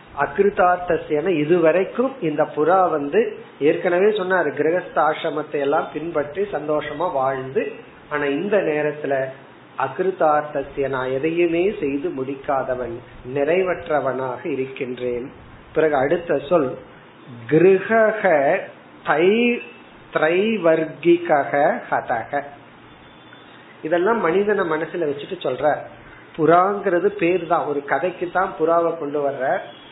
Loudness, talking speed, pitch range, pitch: -20 LUFS, 75 wpm, 140-180 Hz, 155 Hz